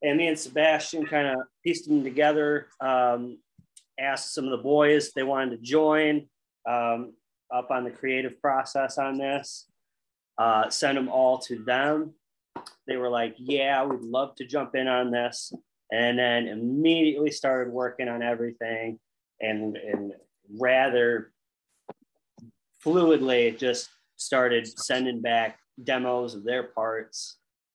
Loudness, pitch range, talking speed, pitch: -26 LUFS, 120-145 Hz, 140 wpm, 130 Hz